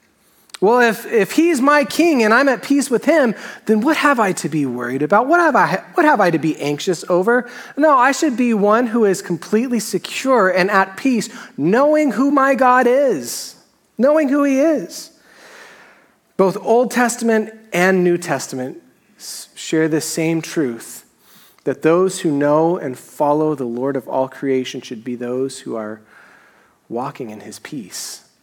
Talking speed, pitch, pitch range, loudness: 170 wpm, 205 Hz, 155-265 Hz, -16 LUFS